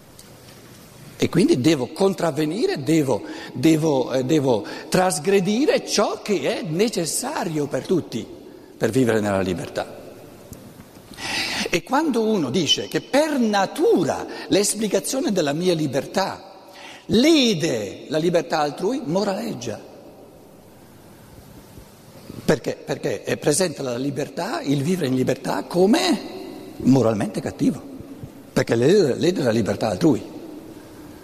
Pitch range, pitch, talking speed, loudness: 145-220 Hz, 175 Hz, 100 wpm, -21 LUFS